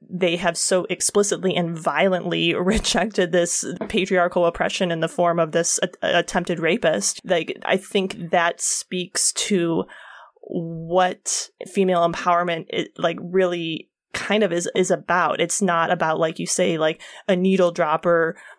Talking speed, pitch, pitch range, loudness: 145 wpm, 175 Hz, 170-185 Hz, -21 LUFS